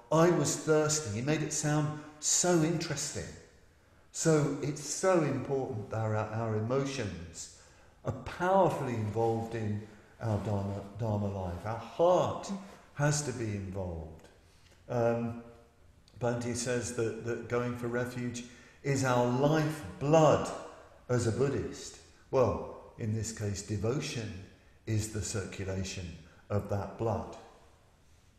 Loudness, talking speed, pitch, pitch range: -32 LUFS, 120 wpm, 115 Hz, 100-140 Hz